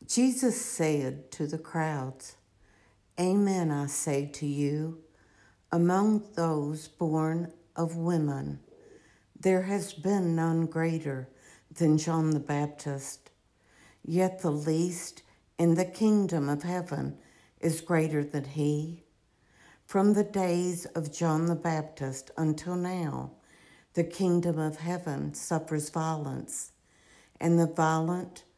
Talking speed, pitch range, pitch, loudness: 115 wpm, 145-175 Hz, 160 Hz, -30 LUFS